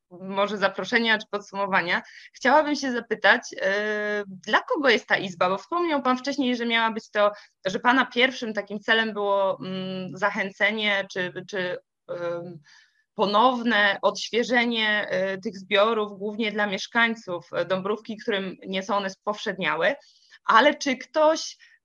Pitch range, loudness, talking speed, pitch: 195-240 Hz, -24 LUFS, 135 wpm, 210 Hz